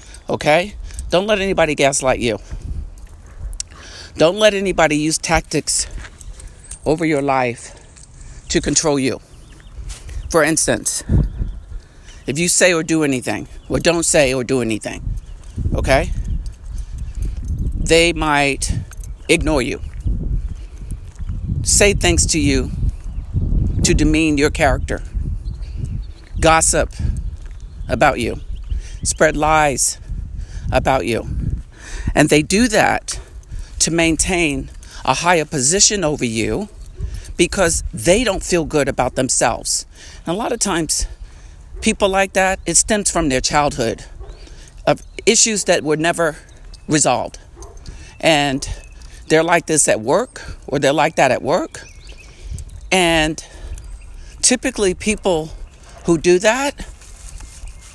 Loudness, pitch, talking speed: -17 LUFS, 135 Hz, 110 wpm